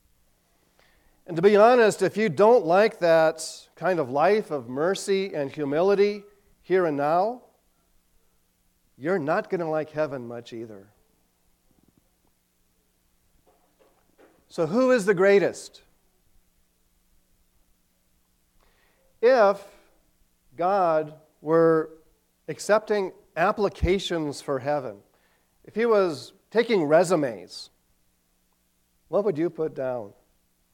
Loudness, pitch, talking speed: -23 LUFS, 155 Hz, 95 wpm